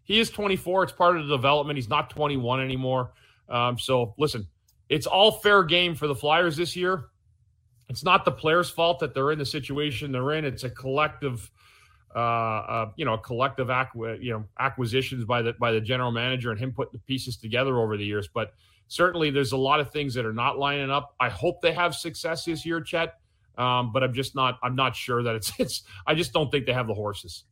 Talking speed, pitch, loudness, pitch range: 225 wpm, 130 Hz, -25 LUFS, 120-155 Hz